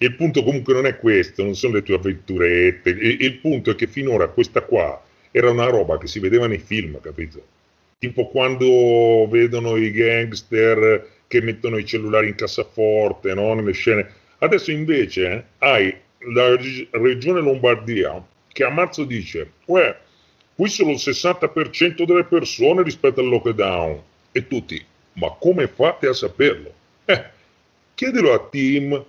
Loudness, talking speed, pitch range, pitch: -18 LUFS, 155 wpm, 110-150 Hz, 125 Hz